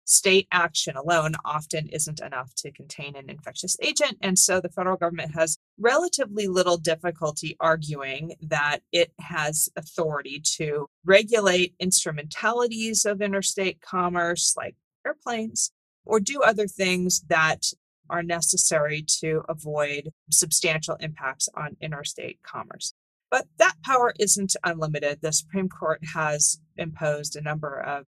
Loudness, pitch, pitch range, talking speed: -24 LUFS, 165 Hz, 155-190 Hz, 130 wpm